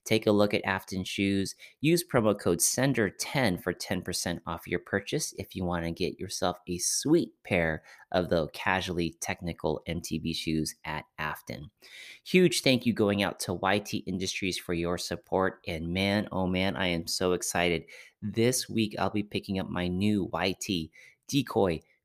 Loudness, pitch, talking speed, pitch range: -29 LUFS, 95 Hz, 165 wpm, 85-105 Hz